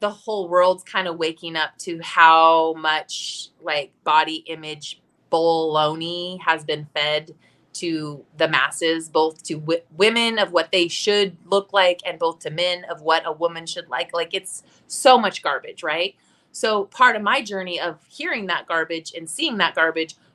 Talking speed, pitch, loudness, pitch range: 175 wpm, 170 Hz, -21 LUFS, 160-190 Hz